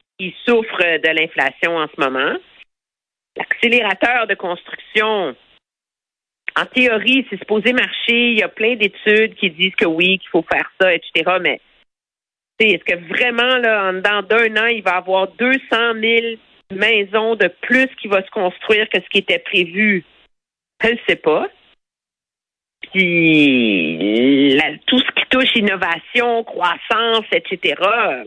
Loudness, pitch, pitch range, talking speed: -15 LUFS, 210 Hz, 180-230 Hz, 140 wpm